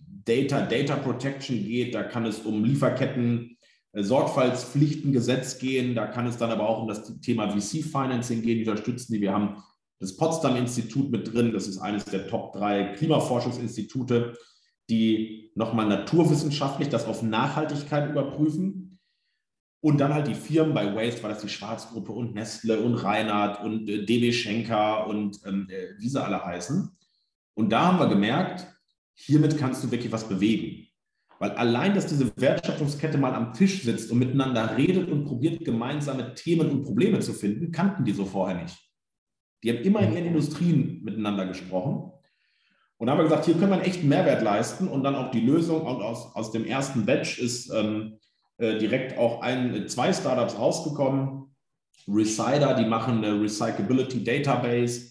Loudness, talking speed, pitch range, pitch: -26 LUFS, 160 wpm, 110-145 Hz, 120 Hz